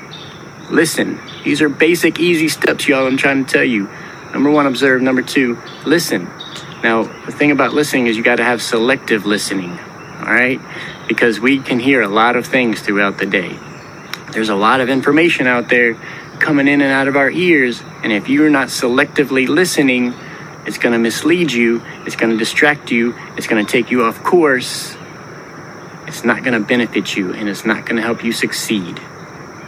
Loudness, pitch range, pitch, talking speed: -14 LUFS, 115-150 Hz, 130 Hz, 190 wpm